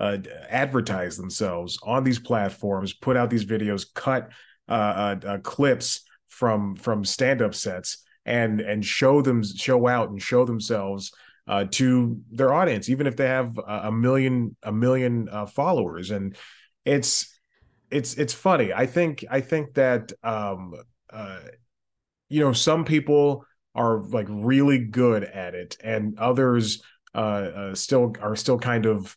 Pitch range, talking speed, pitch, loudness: 100-130 Hz, 150 wpm, 115 Hz, -24 LUFS